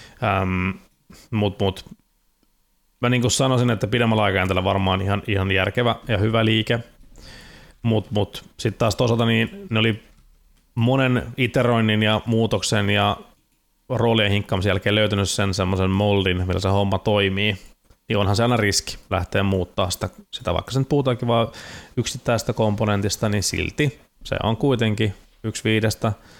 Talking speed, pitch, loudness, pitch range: 140 wpm, 105 Hz, -21 LUFS, 100-115 Hz